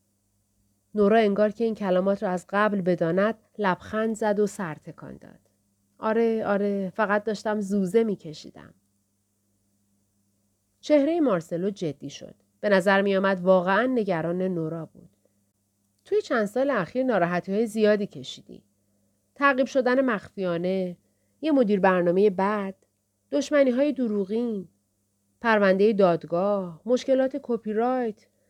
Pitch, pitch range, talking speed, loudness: 195 Hz, 155-220 Hz, 110 wpm, -24 LUFS